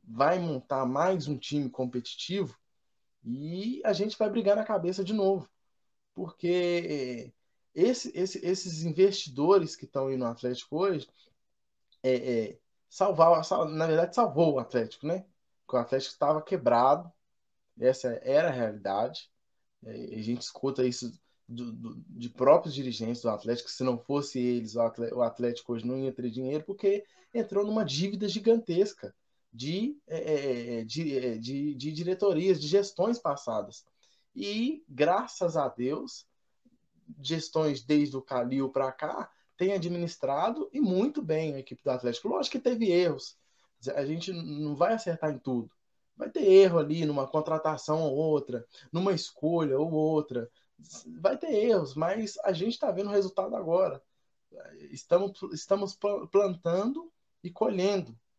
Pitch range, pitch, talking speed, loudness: 130-195 Hz, 160 Hz, 145 wpm, -29 LUFS